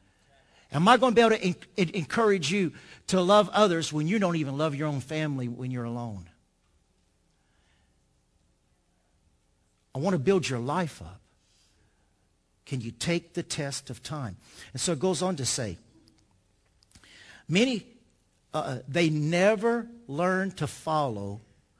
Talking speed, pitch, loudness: 140 wpm, 135 Hz, -27 LUFS